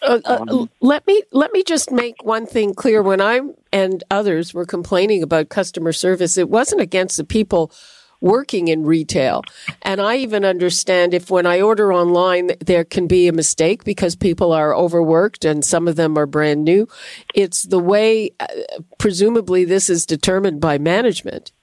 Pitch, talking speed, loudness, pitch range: 185 Hz, 170 wpm, -16 LUFS, 170-215 Hz